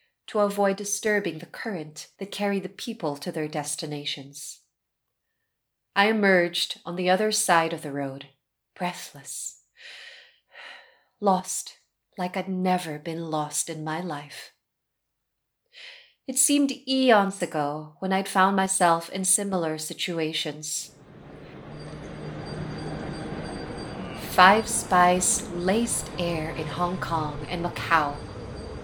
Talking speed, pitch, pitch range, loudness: 105 wpm, 180 Hz, 155-200 Hz, -25 LUFS